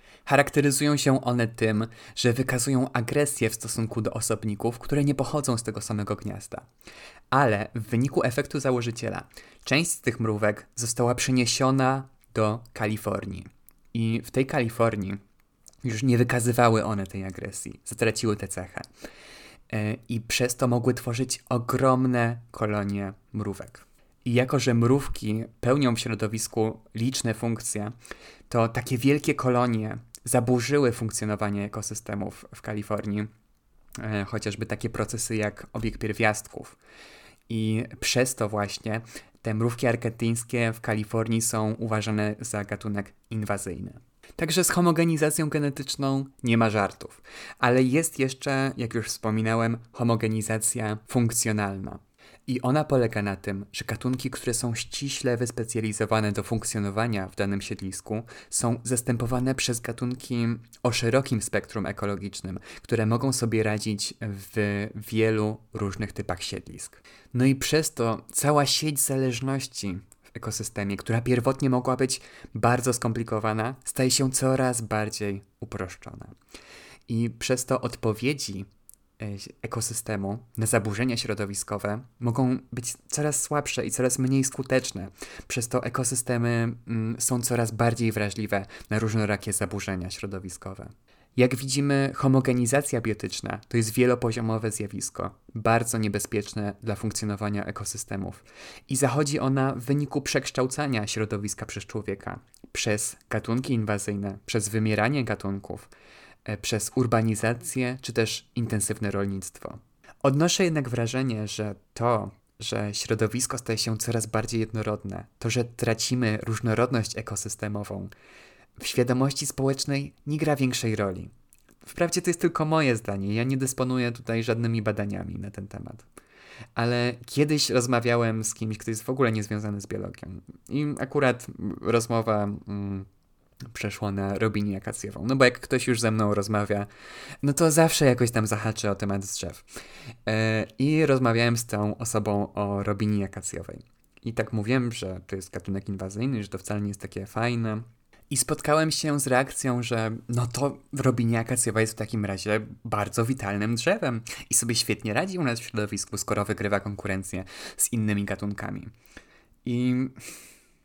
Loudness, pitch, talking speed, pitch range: -27 LUFS, 115 Hz, 130 wpm, 105-125 Hz